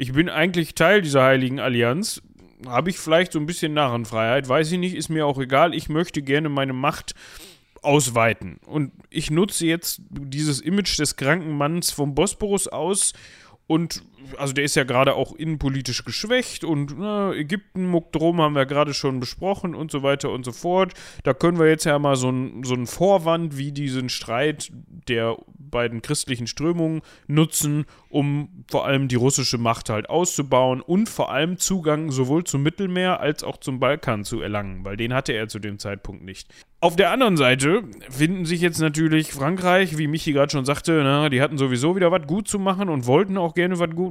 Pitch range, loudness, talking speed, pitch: 130-170 Hz, -22 LUFS, 190 wpm, 150 Hz